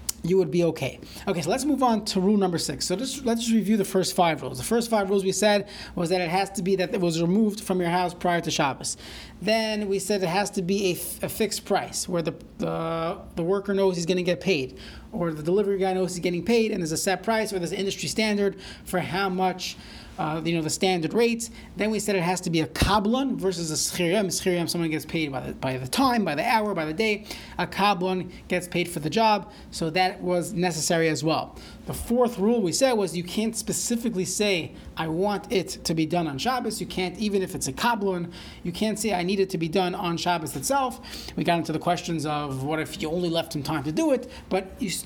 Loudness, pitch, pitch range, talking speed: -25 LUFS, 185 Hz, 170-210 Hz, 250 wpm